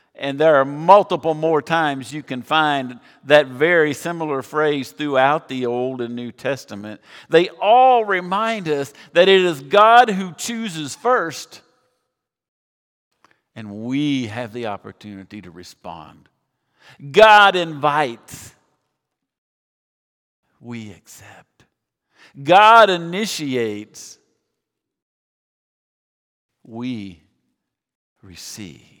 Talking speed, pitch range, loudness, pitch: 95 wpm, 120-175 Hz, -17 LUFS, 145 Hz